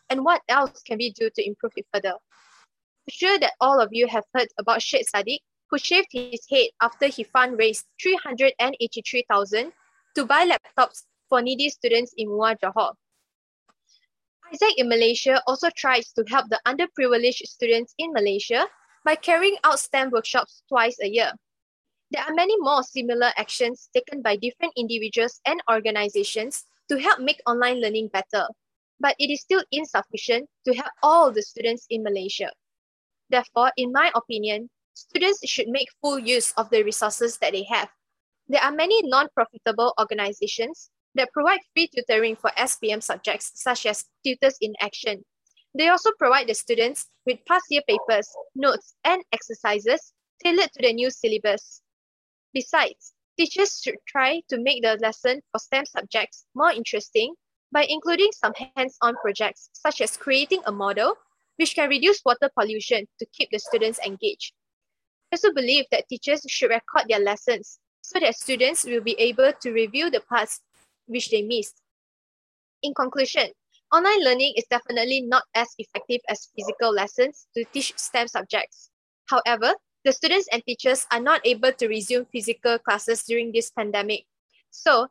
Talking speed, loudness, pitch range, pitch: 160 wpm, -23 LUFS, 230-290 Hz, 250 Hz